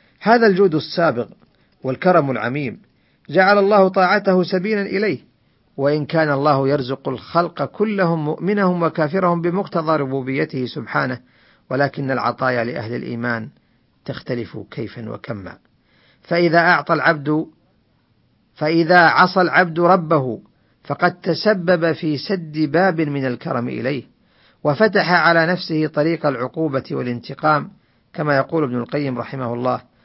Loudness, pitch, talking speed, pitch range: -18 LUFS, 155 Hz, 110 wpm, 130-180 Hz